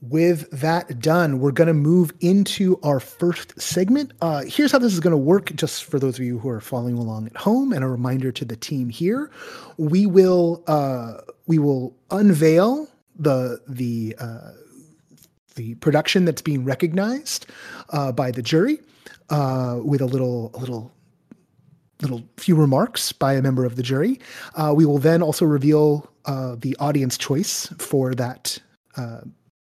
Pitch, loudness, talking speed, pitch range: 150 Hz, -21 LUFS, 170 wpm, 130-175 Hz